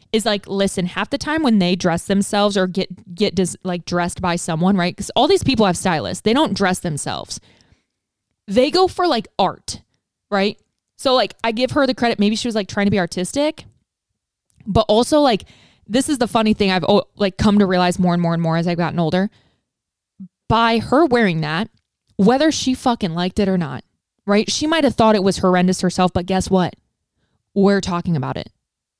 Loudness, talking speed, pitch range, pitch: -18 LUFS, 205 wpm, 180-230 Hz, 200 Hz